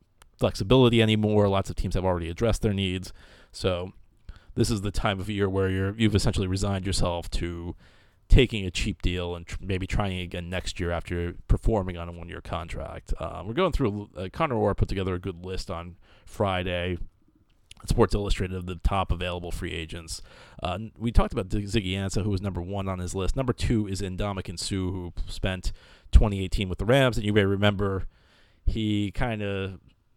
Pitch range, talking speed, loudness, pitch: 90-105 Hz, 190 wpm, -27 LUFS, 95 Hz